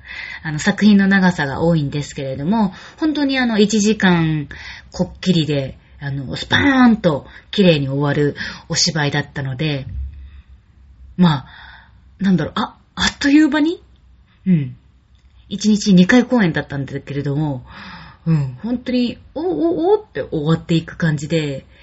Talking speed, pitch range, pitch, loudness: 270 characters per minute, 140-210 Hz, 165 Hz, -17 LUFS